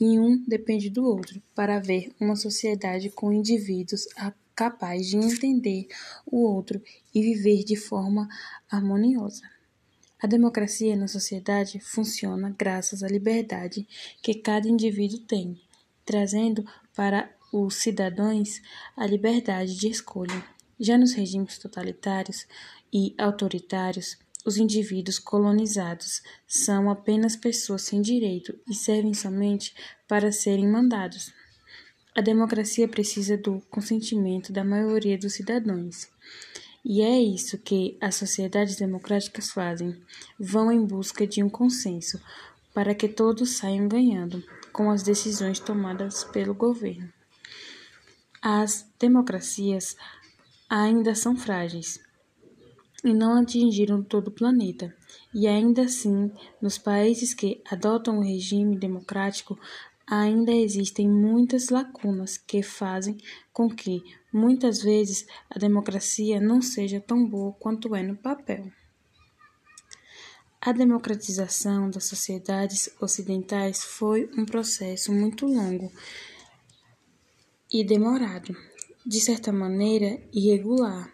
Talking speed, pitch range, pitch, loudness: 115 wpm, 195-225 Hz, 210 Hz, -25 LUFS